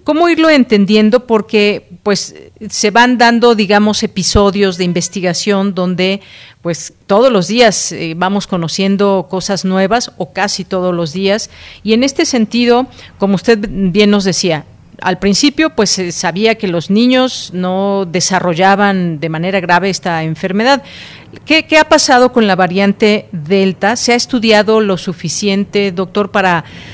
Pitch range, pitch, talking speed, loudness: 185-225 Hz, 200 Hz, 145 wpm, -12 LUFS